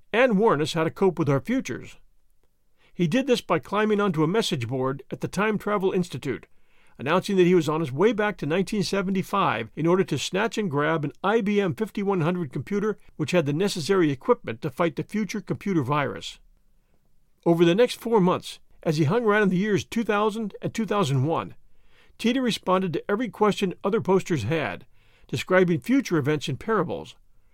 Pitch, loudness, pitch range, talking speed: 185 Hz, -24 LUFS, 160-210 Hz, 180 wpm